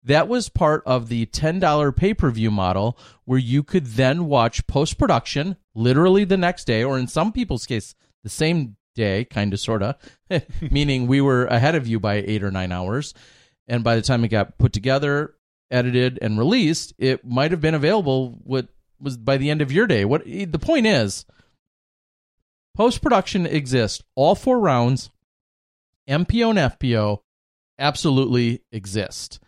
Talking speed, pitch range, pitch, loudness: 170 wpm, 110-150 Hz, 130 Hz, -21 LUFS